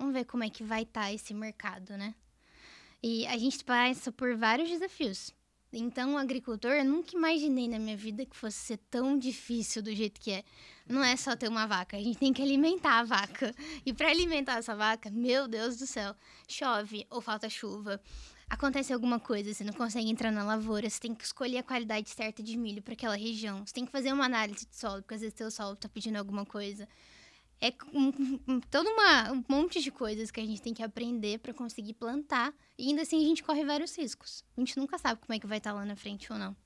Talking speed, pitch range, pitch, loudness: 230 wpm, 215-265 Hz, 235 Hz, -33 LUFS